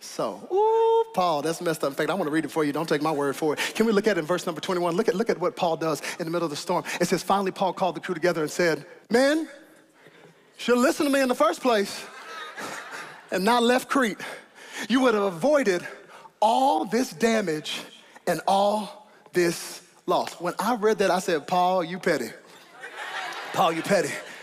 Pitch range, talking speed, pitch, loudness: 170-235 Hz, 220 wpm, 190 Hz, -25 LUFS